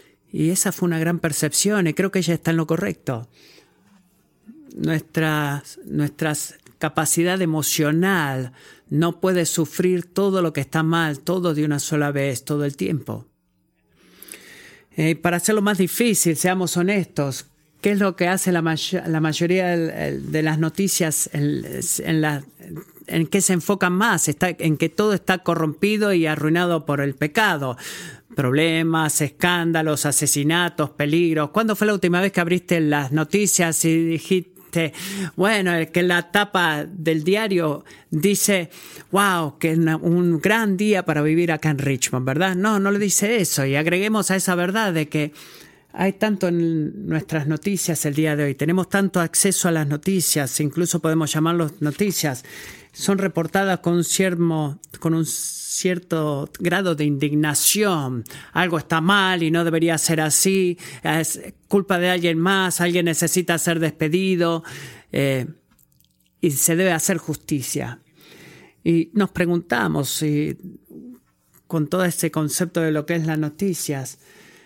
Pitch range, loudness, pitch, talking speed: 155-185 Hz, -20 LUFS, 165 Hz, 150 wpm